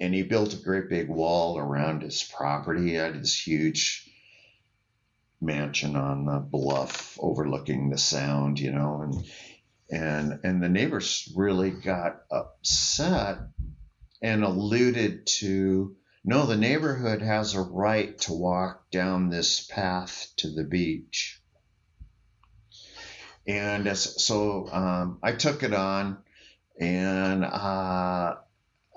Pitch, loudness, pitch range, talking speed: 95 Hz, -27 LUFS, 80-105 Hz, 120 wpm